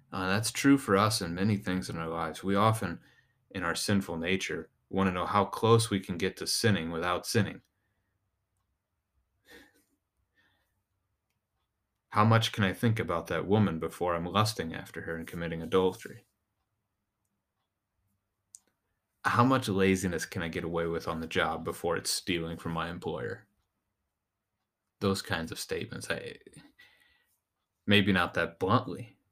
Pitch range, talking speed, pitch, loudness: 90-105 Hz, 145 wpm, 95 Hz, -30 LUFS